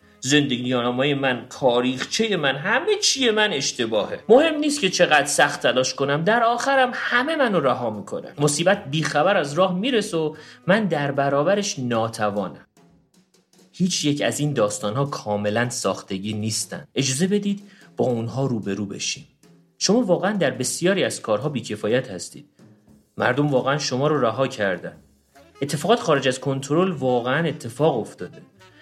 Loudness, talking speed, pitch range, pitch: -21 LUFS, 140 wpm, 125-190 Hz, 145 Hz